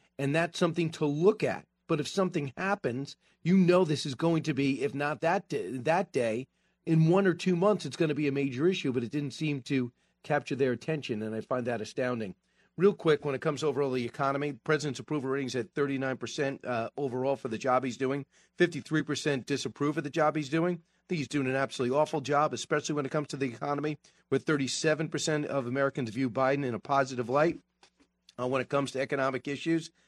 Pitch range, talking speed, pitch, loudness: 135-160 Hz, 215 wpm, 145 Hz, -30 LUFS